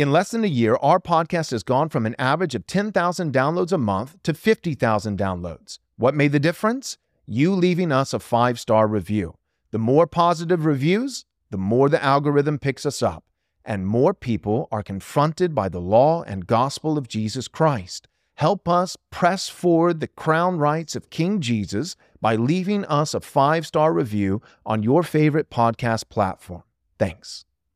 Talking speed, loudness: 170 wpm, -21 LUFS